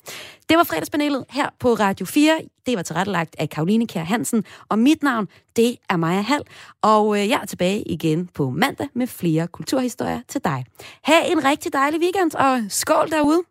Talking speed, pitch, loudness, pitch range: 180 wpm, 240 Hz, -20 LUFS, 190-295 Hz